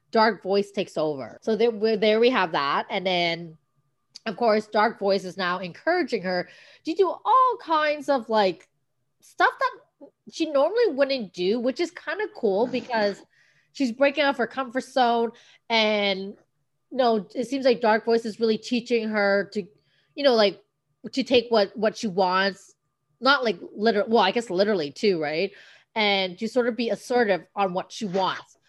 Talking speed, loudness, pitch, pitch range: 180 wpm, -24 LUFS, 220 Hz, 190-250 Hz